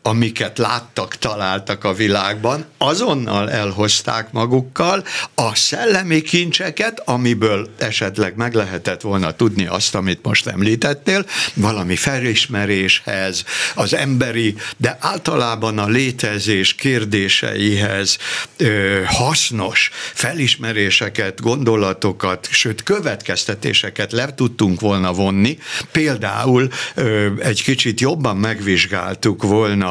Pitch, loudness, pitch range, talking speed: 110 Hz, -17 LUFS, 100-125 Hz, 95 wpm